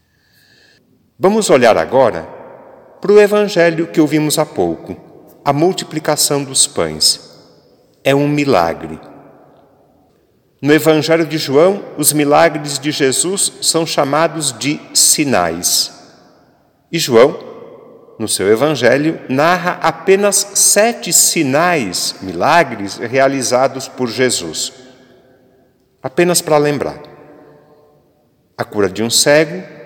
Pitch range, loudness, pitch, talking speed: 130-170 Hz, -13 LUFS, 150 Hz, 100 wpm